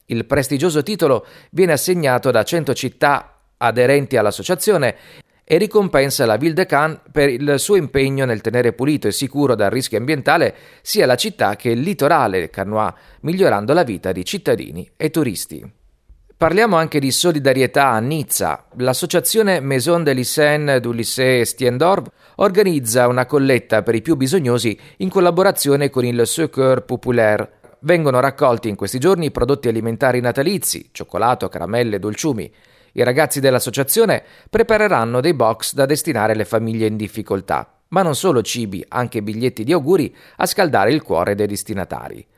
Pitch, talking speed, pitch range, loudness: 130 Hz, 150 wpm, 115-155 Hz, -17 LUFS